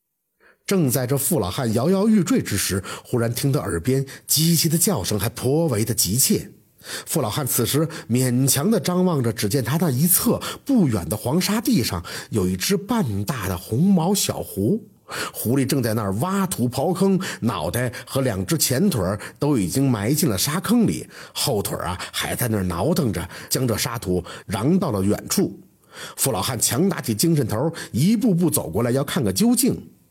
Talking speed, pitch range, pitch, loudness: 255 characters per minute, 115-180 Hz, 135 Hz, -21 LUFS